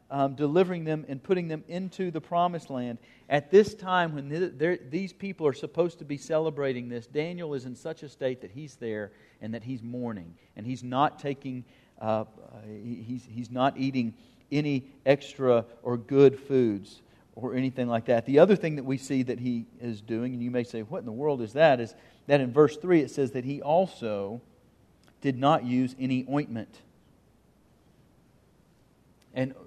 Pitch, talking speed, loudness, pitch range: 135 Hz, 180 wpm, -28 LUFS, 120-150 Hz